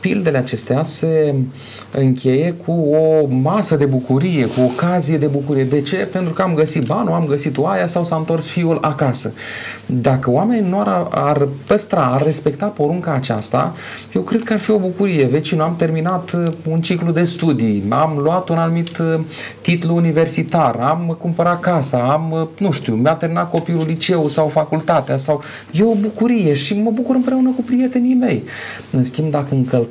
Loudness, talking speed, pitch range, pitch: -17 LUFS, 175 wpm, 140-175 Hz, 160 Hz